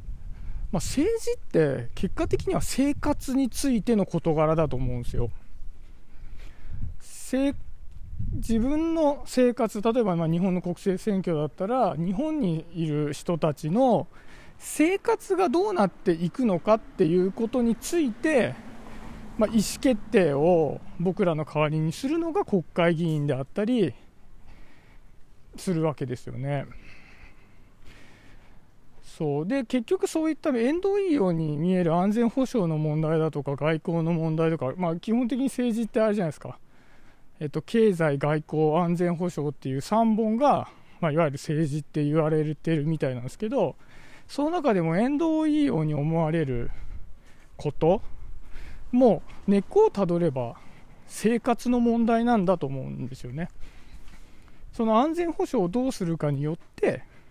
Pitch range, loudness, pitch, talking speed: 150-235 Hz, -26 LUFS, 175 Hz, 285 characters per minute